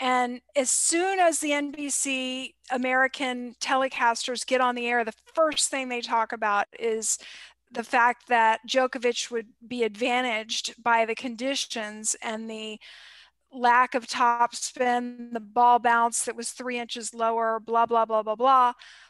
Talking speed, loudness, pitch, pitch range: 150 wpm, -25 LUFS, 240 Hz, 230-260 Hz